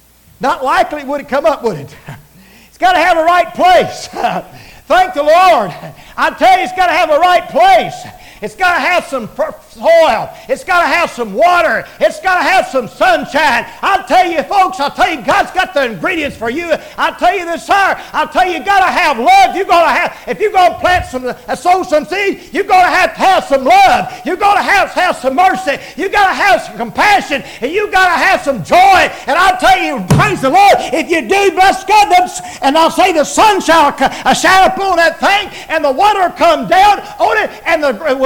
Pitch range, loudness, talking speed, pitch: 295-370 Hz, -11 LUFS, 225 wpm, 345 Hz